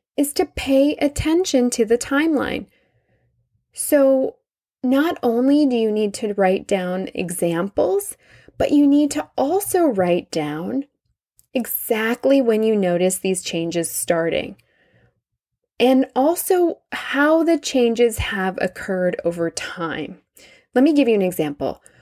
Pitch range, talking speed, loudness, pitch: 185-285 Hz, 125 wpm, -19 LUFS, 245 Hz